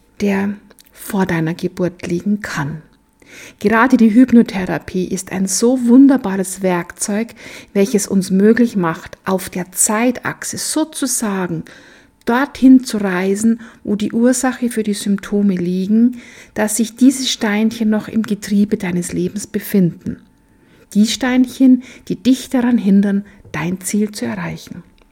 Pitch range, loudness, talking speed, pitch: 190-240 Hz, -16 LUFS, 125 wpm, 210 Hz